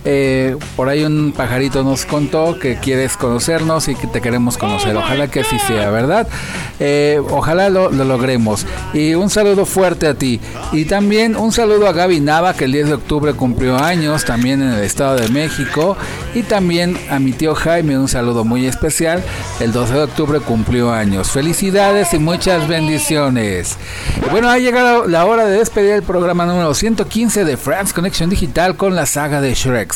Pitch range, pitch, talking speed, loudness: 130-180 Hz, 150 Hz, 180 wpm, -14 LUFS